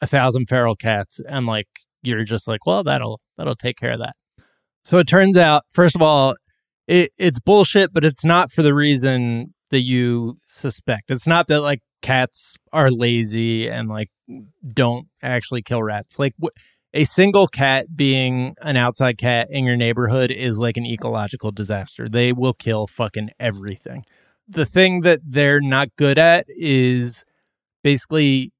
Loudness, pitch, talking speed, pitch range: -18 LUFS, 130 Hz, 165 wpm, 120-150 Hz